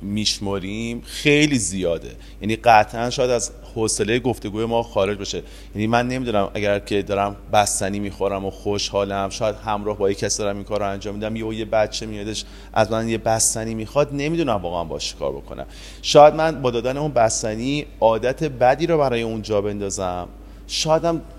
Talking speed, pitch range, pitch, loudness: 170 wpm, 100-120 Hz, 110 Hz, -21 LUFS